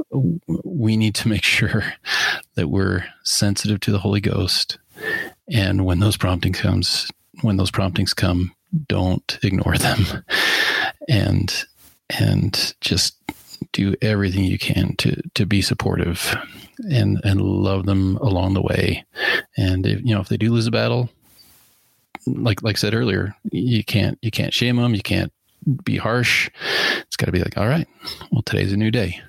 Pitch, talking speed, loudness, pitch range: 105 Hz, 160 wpm, -20 LUFS, 95-115 Hz